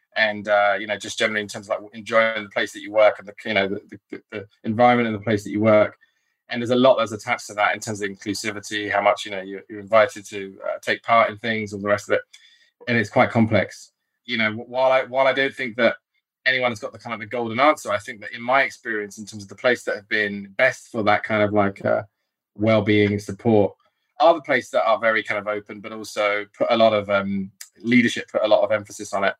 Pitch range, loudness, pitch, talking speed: 105-120 Hz, -21 LUFS, 110 Hz, 265 wpm